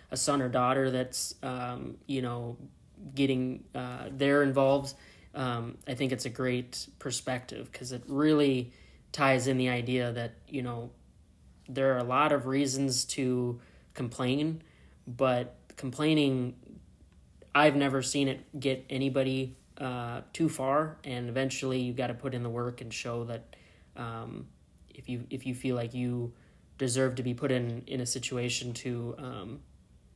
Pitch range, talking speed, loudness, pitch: 120-135 Hz, 155 wpm, -31 LUFS, 130 Hz